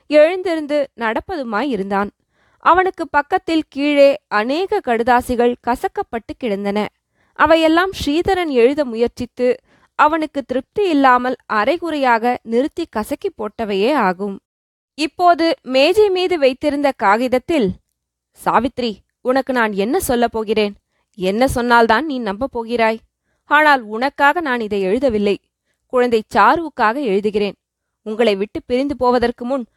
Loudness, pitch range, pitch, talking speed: -17 LUFS, 225-300 Hz, 255 Hz, 100 wpm